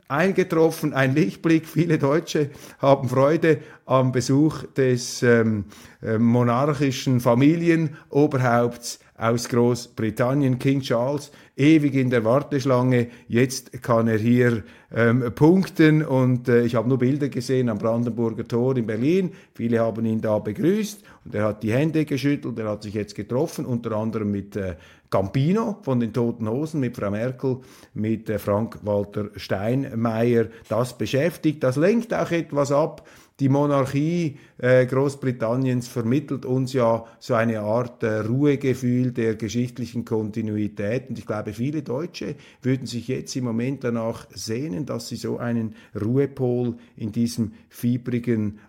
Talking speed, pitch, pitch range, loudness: 140 wpm, 125 Hz, 115-140 Hz, -23 LUFS